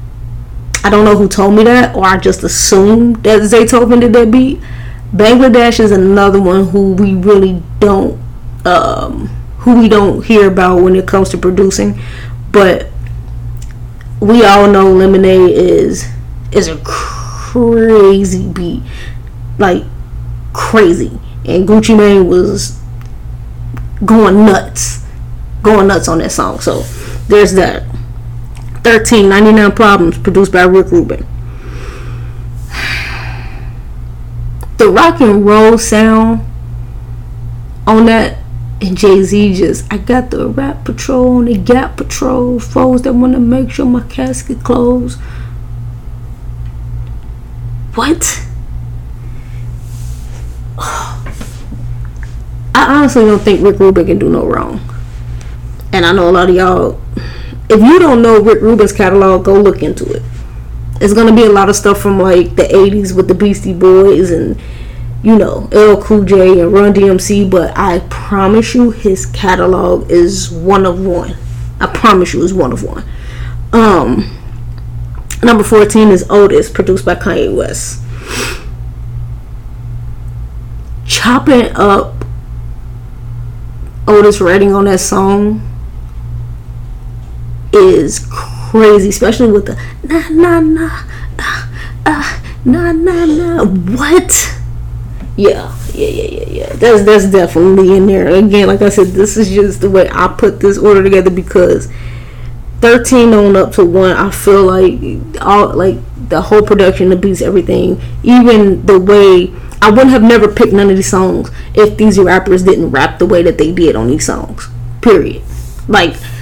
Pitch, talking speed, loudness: 185 Hz, 135 wpm, -8 LUFS